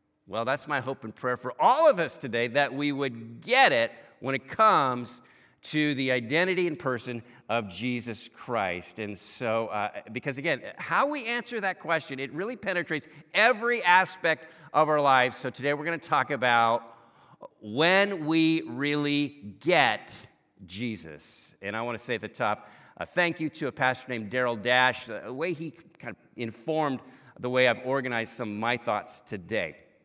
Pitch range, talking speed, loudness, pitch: 120-160 Hz, 180 wpm, -27 LUFS, 135 Hz